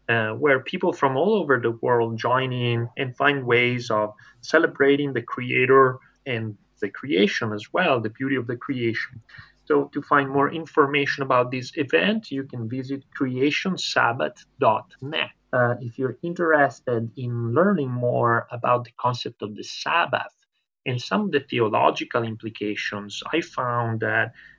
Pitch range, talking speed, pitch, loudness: 120-140 Hz, 150 wpm, 130 Hz, -23 LUFS